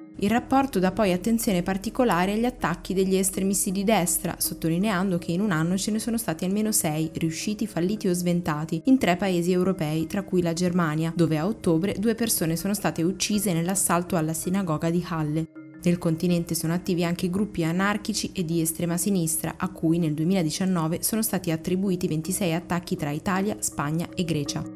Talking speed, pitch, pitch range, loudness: 175 wpm, 180 Hz, 165-195 Hz, -25 LUFS